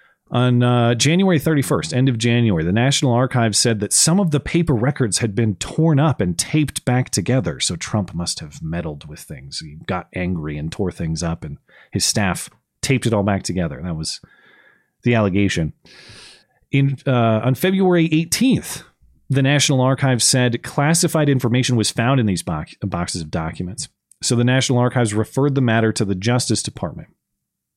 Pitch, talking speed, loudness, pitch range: 120 Hz, 175 wpm, -18 LUFS, 100-140 Hz